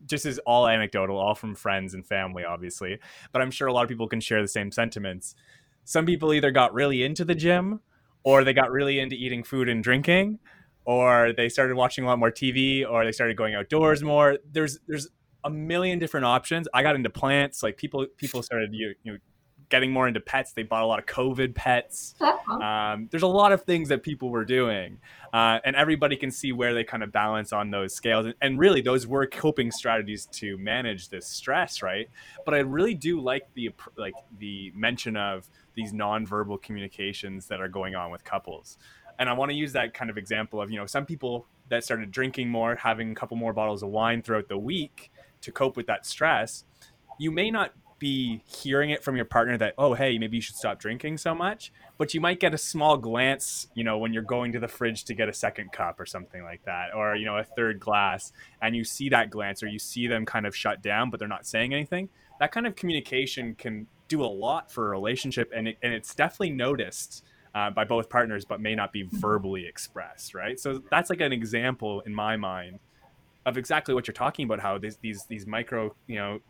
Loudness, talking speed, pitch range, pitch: -26 LUFS, 220 wpm, 110-140 Hz, 120 Hz